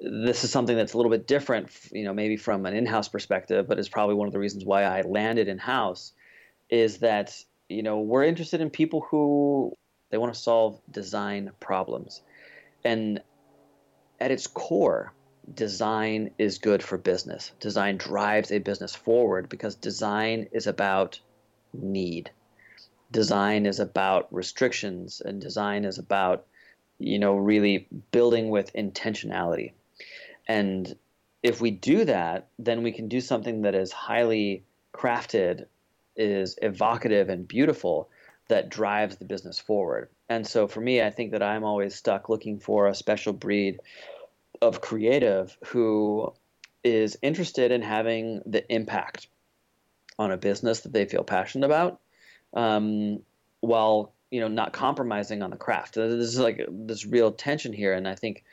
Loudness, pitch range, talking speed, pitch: -26 LUFS, 100-115 Hz, 155 wpm, 105 Hz